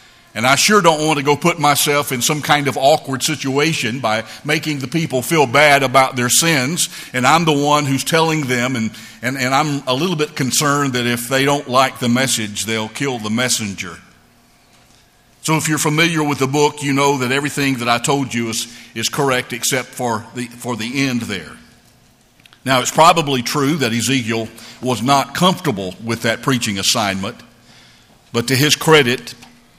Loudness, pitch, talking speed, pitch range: -16 LUFS, 135 Hz, 185 wpm, 120-150 Hz